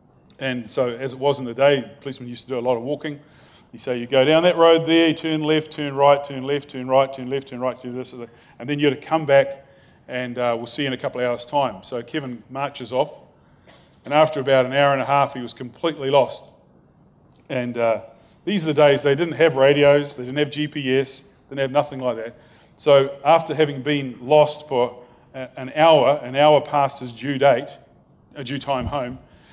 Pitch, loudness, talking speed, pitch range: 140 Hz, -20 LUFS, 230 wpm, 125-145 Hz